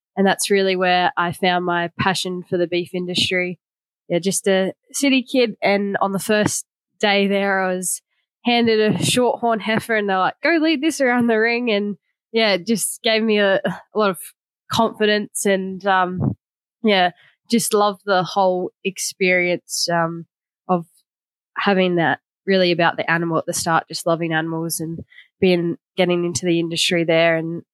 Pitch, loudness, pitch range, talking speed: 190 Hz, -19 LUFS, 175-210 Hz, 170 wpm